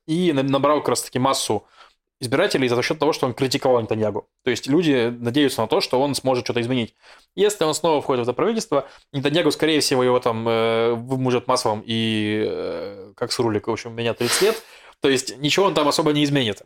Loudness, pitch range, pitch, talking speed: -21 LUFS, 120-145 Hz, 130 Hz, 210 wpm